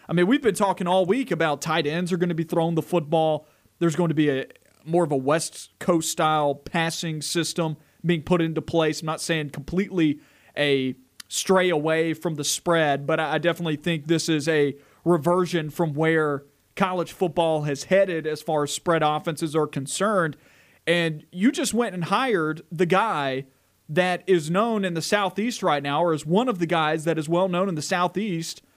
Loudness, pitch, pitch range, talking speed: -24 LUFS, 165 Hz, 155-180 Hz, 195 wpm